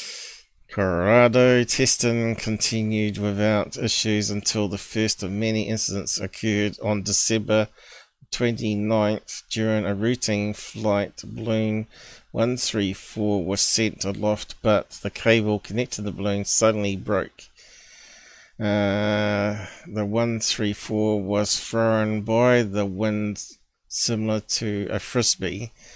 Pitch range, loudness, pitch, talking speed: 105-110 Hz, -22 LUFS, 105 Hz, 100 wpm